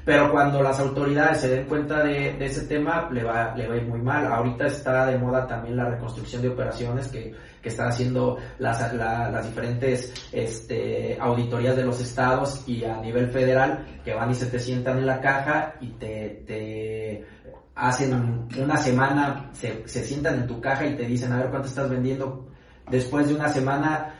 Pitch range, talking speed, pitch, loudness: 120-135 Hz, 195 wpm, 130 Hz, -25 LUFS